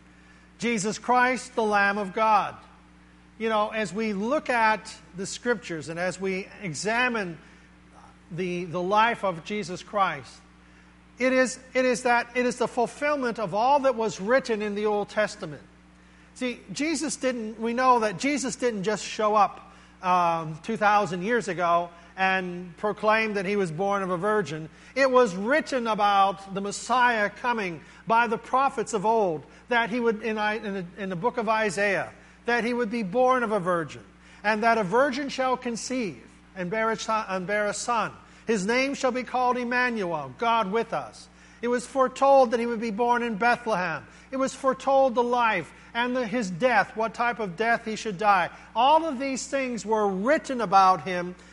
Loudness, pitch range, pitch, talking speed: -25 LUFS, 190-245 Hz, 220 Hz, 175 wpm